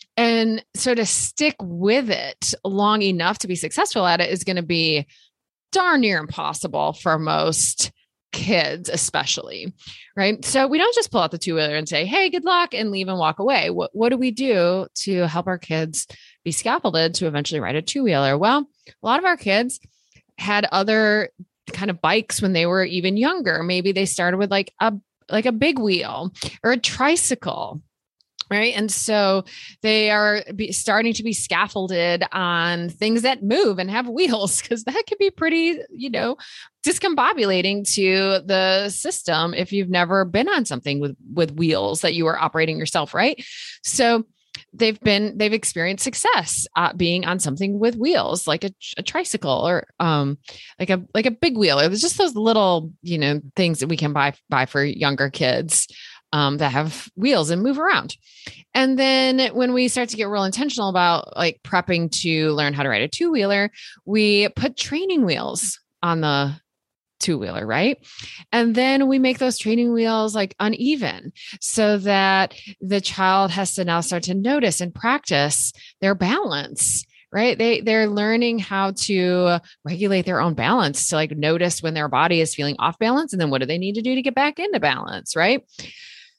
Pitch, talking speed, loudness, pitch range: 195 Hz, 185 wpm, -20 LUFS, 170-230 Hz